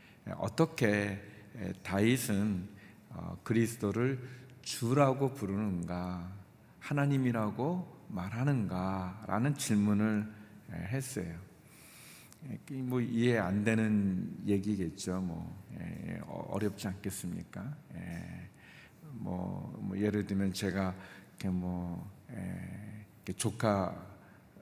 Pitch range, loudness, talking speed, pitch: 95-125 Hz, -34 LUFS, 180 characters per minute, 105 Hz